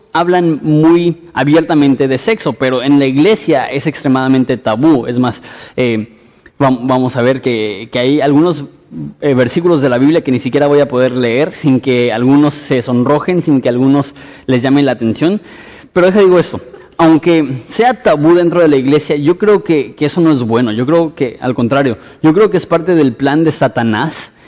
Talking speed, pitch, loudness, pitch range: 190 wpm, 140 Hz, -11 LUFS, 125-160 Hz